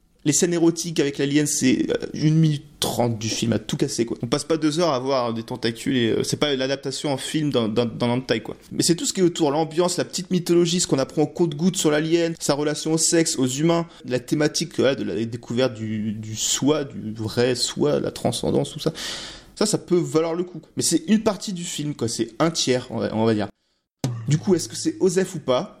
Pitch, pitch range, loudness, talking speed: 150 Hz, 125-165 Hz, -22 LUFS, 250 wpm